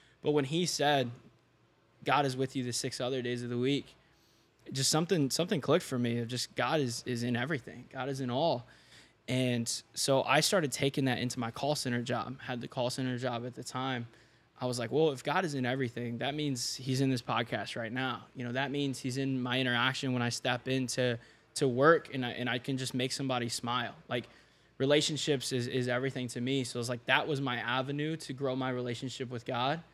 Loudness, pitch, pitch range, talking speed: -32 LUFS, 130 Hz, 120-140 Hz, 225 wpm